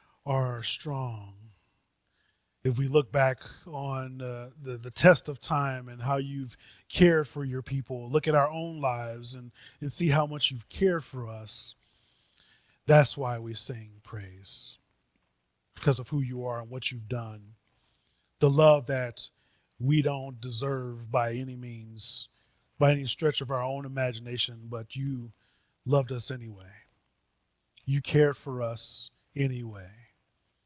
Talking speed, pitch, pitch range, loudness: 145 wpm, 130 Hz, 115-140 Hz, -29 LUFS